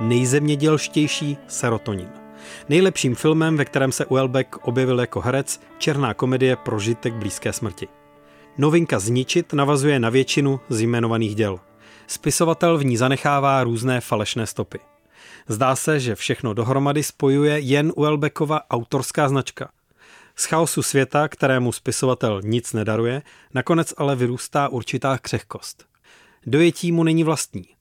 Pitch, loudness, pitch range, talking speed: 130 Hz, -21 LUFS, 115-150 Hz, 120 wpm